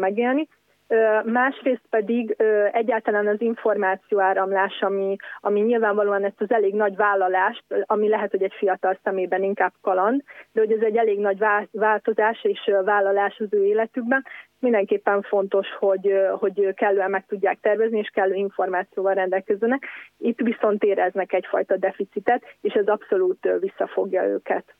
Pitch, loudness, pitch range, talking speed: 210 Hz, -22 LUFS, 195-225 Hz, 140 wpm